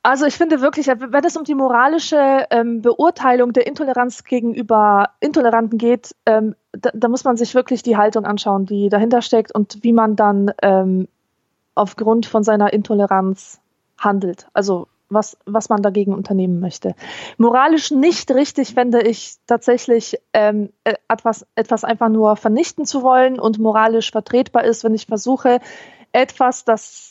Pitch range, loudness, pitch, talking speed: 210-255 Hz, -16 LUFS, 230 Hz, 140 wpm